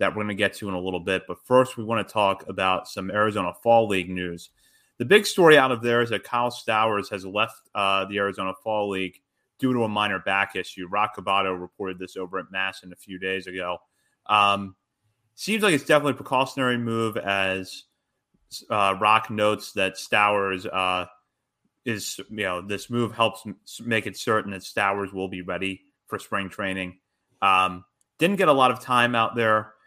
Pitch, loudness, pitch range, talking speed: 100 Hz, -24 LUFS, 95-115 Hz, 195 wpm